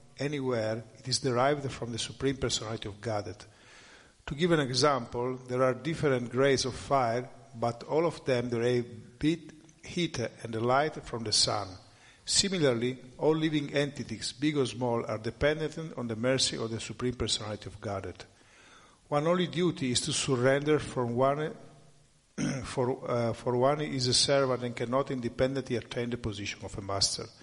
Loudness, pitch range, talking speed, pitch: -30 LUFS, 115-140 Hz, 160 wpm, 125 Hz